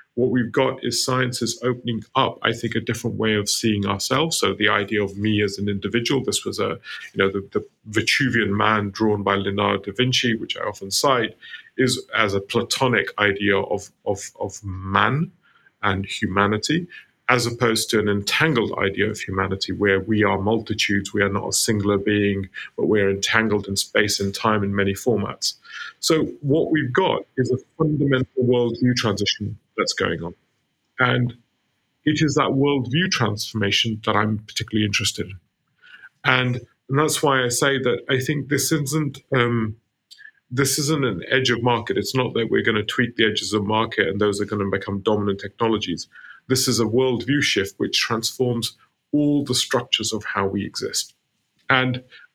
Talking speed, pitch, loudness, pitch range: 180 wpm, 110 Hz, -21 LUFS, 100-125 Hz